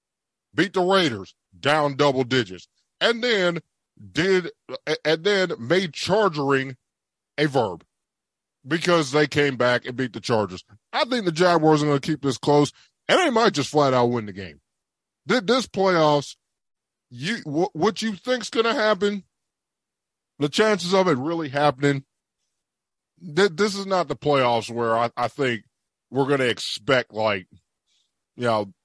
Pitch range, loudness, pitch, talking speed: 120-185 Hz, -22 LUFS, 145 Hz, 150 wpm